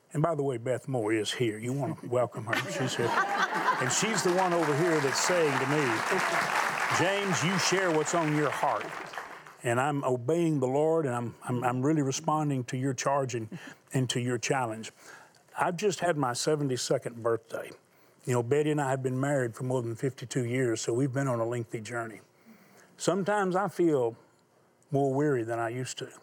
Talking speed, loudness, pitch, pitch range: 195 wpm, -29 LUFS, 135 Hz, 125-155 Hz